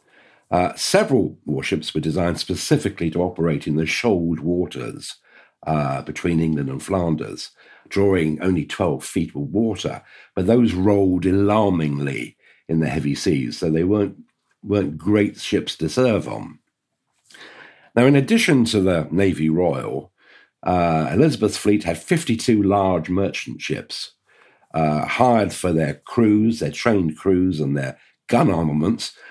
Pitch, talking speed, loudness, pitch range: 90 Hz, 135 wpm, -20 LUFS, 80-105 Hz